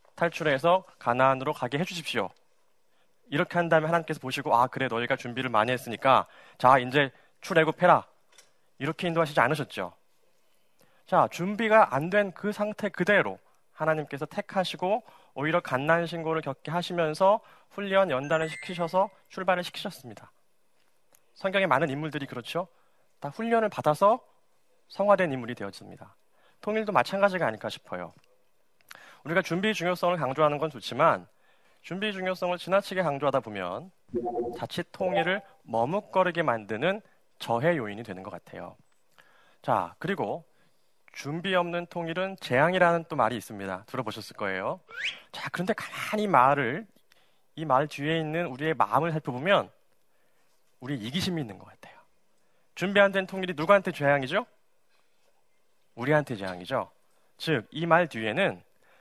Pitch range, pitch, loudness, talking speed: 135-190 Hz, 165 Hz, -27 LUFS, 320 characters per minute